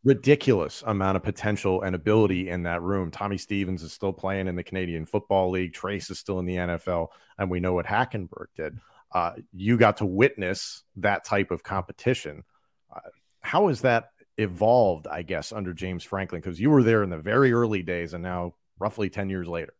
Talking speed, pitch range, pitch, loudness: 195 wpm, 90-105 Hz, 95 Hz, -26 LUFS